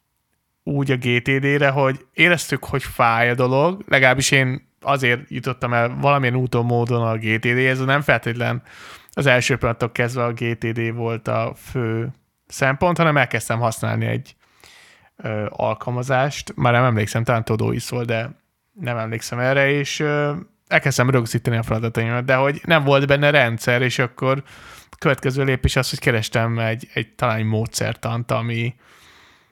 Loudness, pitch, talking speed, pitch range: -19 LUFS, 125 Hz, 150 wpm, 115-135 Hz